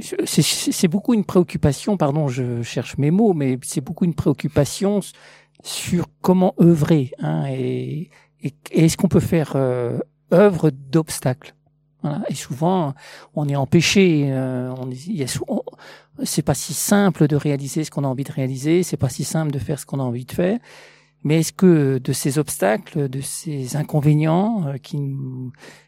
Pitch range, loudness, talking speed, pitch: 135-175 Hz, -20 LUFS, 180 wpm, 150 Hz